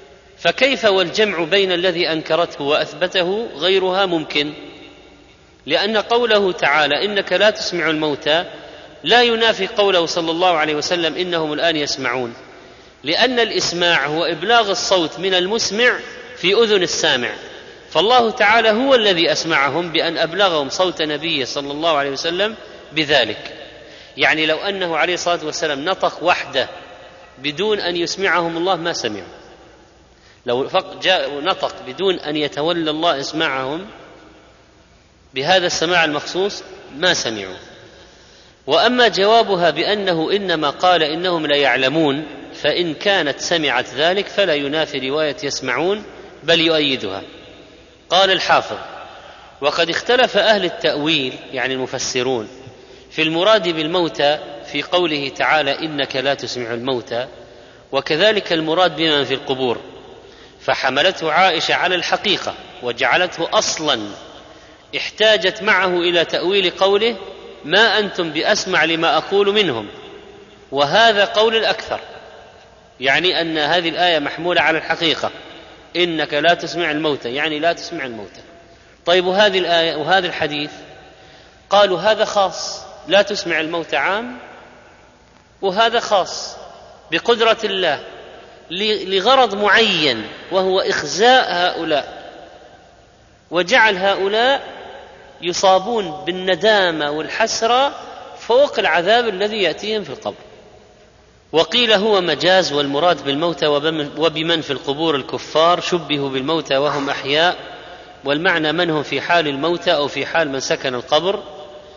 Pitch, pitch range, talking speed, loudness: 170 Hz, 150-200 Hz, 115 wpm, -17 LUFS